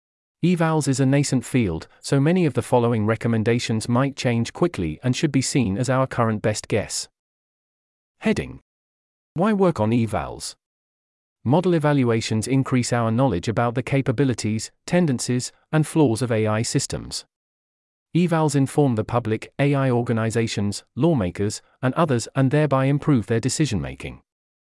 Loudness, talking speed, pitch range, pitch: -22 LUFS, 140 wpm, 110-140 Hz, 125 Hz